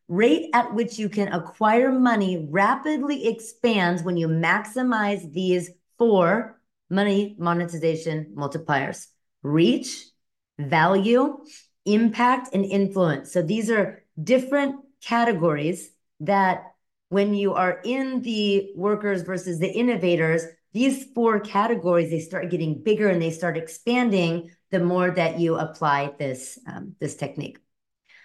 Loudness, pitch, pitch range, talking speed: -23 LUFS, 195 Hz, 170-230 Hz, 120 wpm